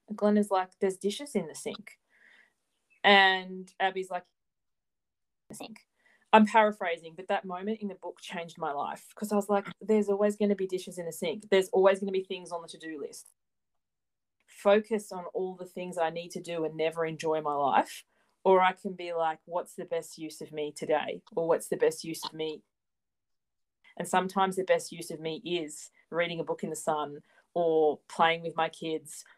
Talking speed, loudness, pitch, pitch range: 205 wpm, -30 LUFS, 180 Hz, 160-200 Hz